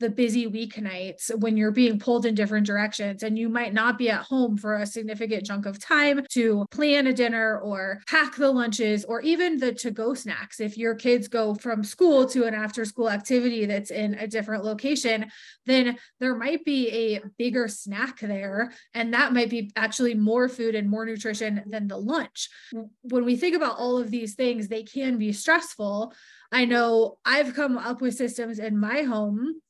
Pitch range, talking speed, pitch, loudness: 215-250 Hz, 195 wpm, 230 Hz, -25 LUFS